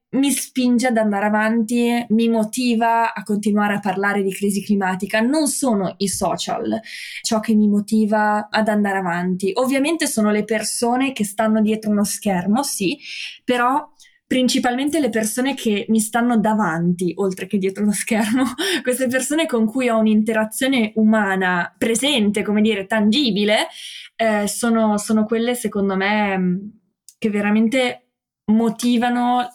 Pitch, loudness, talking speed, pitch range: 220 Hz, -19 LUFS, 140 wpm, 205-245 Hz